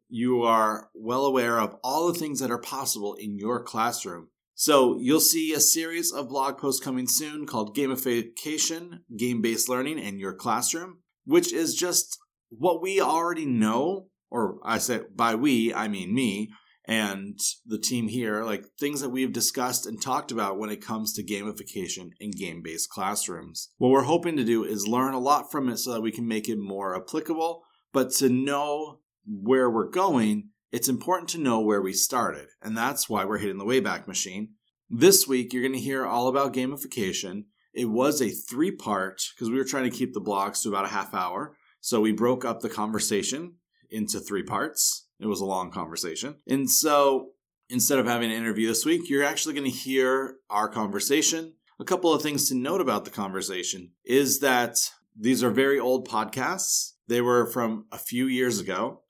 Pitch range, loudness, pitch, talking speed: 110-145 Hz, -26 LUFS, 125 Hz, 190 wpm